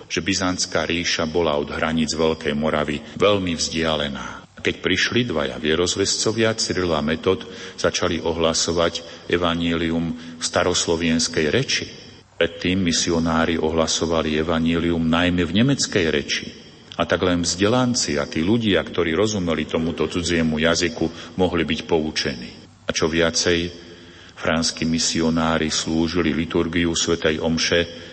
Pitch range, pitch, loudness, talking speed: 80-90 Hz, 85 Hz, -21 LUFS, 115 wpm